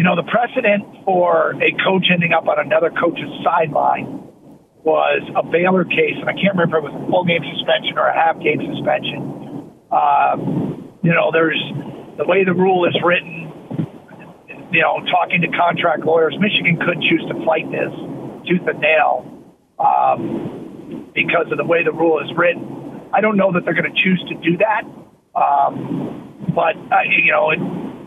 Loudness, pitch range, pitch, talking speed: -17 LUFS, 165-190 Hz, 175 Hz, 180 wpm